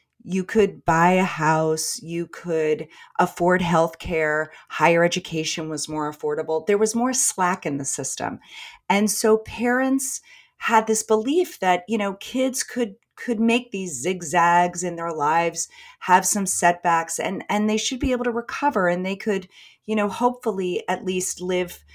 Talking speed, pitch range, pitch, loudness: 165 wpm, 165-220 Hz, 185 Hz, -22 LUFS